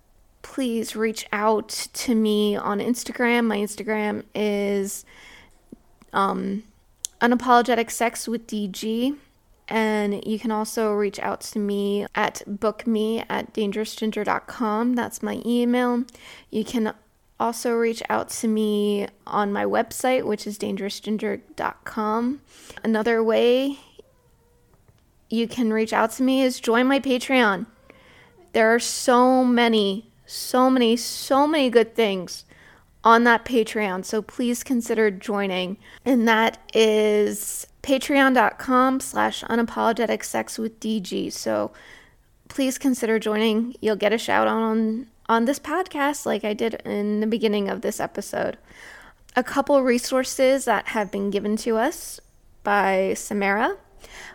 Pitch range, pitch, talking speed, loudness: 210-245 Hz, 225 Hz, 120 wpm, -23 LUFS